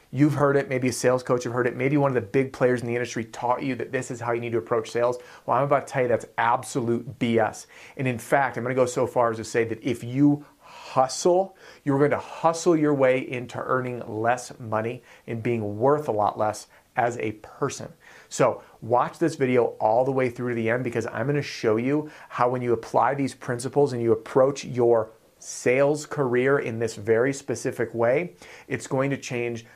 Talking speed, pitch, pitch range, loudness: 220 wpm, 125 Hz, 120-140 Hz, -25 LUFS